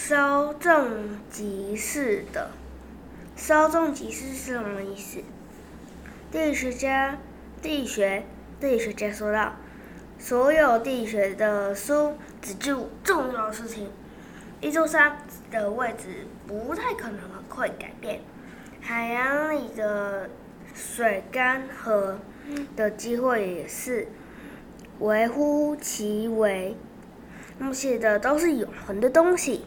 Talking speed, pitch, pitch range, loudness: 165 characters per minute, 240 Hz, 210-285 Hz, -26 LUFS